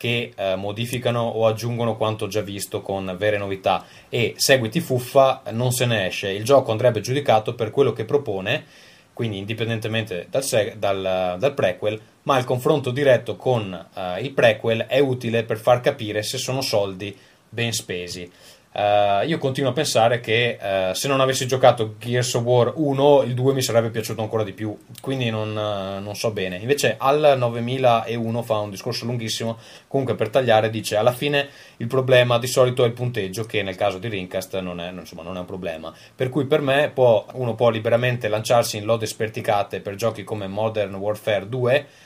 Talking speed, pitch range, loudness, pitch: 185 wpm, 105-125 Hz, -21 LUFS, 115 Hz